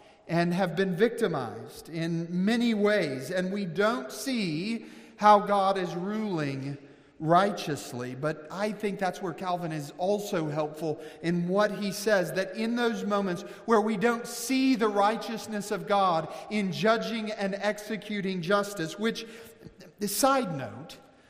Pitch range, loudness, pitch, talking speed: 170-215 Hz, -28 LUFS, 200 Hz, 140 wpm